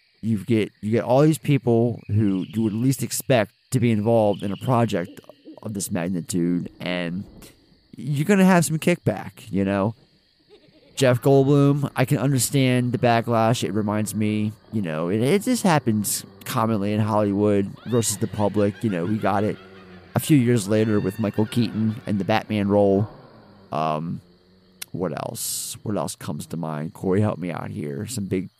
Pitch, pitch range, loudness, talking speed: 110 Hz, 100-125 Hz, -22 LUFS, 170 wpm